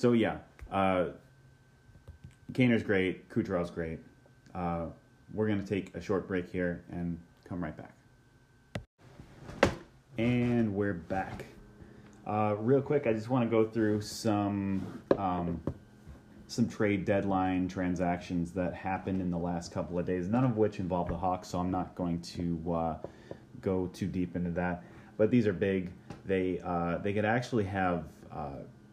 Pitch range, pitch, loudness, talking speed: 90-110 Hz, 95 Hz, -32 LUFS, 155 wpm